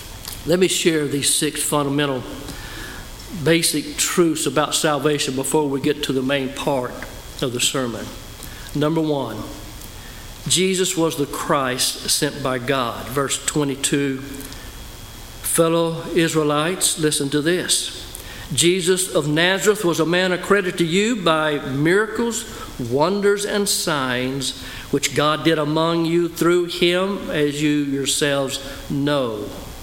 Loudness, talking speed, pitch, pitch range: -19 LUFS, 125 wpm, 150 Hz, 135-170 Hz